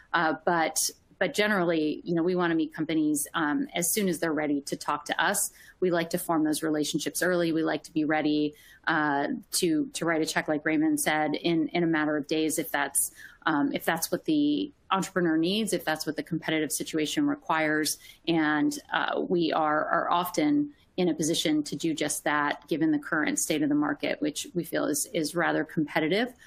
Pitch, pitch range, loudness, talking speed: 160 Hz, 155-180 Hz, -27 LUFS, 205 wpm